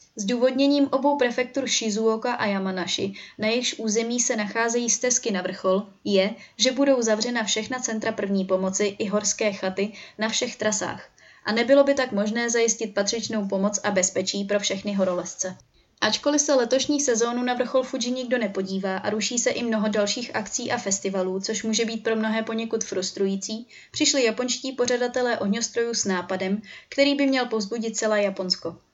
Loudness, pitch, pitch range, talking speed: -24 LUFS, 220 Hz, 200-245 Hz, 160 wpm